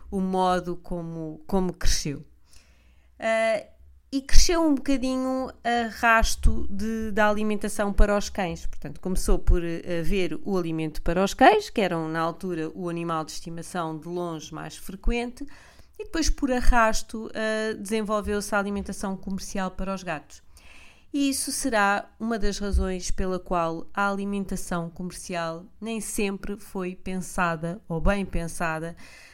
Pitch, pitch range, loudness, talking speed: 195 Hz, 170-220 Hz, -27 LUFS, 145 wpm